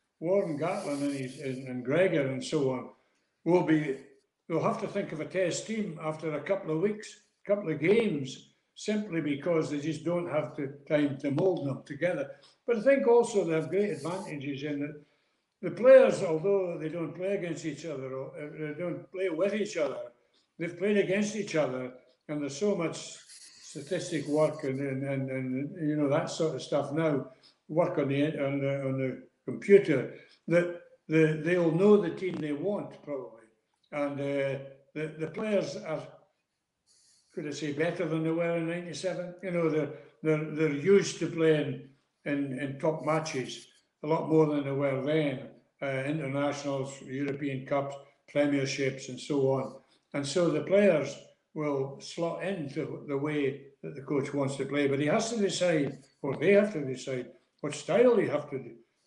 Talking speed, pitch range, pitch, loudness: 180 wpm, 140-175 Hz, 155 Hz, -30 LUFS